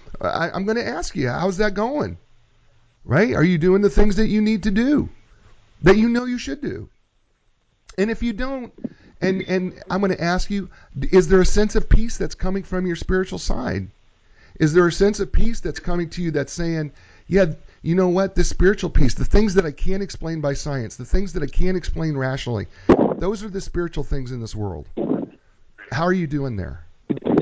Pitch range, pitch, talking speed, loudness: 125-195 Hz, 175 Hz, 210 wpm, -21 LUFS